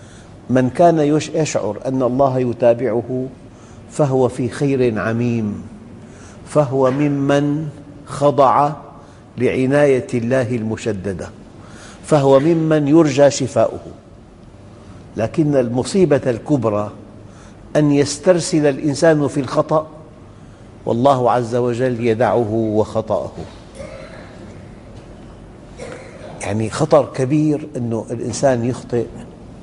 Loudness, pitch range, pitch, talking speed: -17 LUFS, 115-145 Hz, 130 Hz, 80 wpm